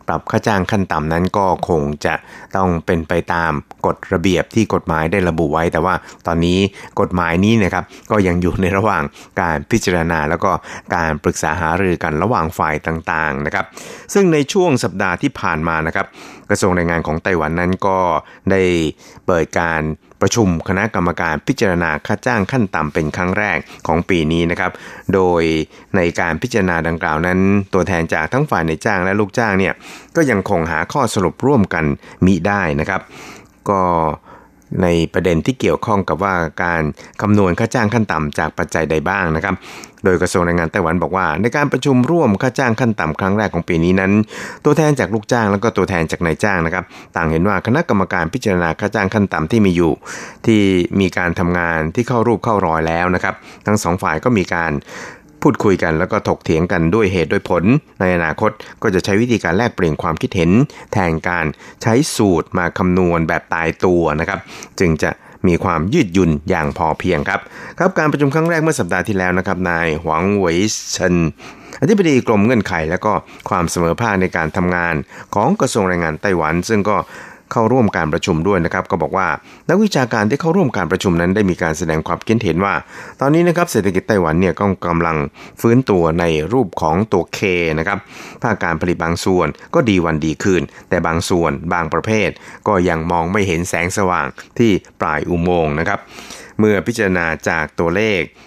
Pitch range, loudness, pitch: 85-105 Hz, -16 LUFS, 90 Hz